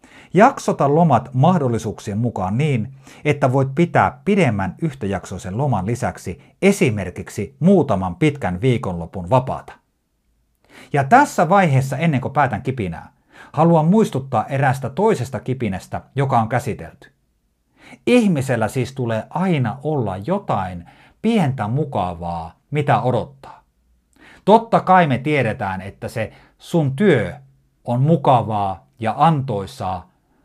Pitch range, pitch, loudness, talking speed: 100-150 Hz, 125 Hz, -19 LUFS, 105 wpm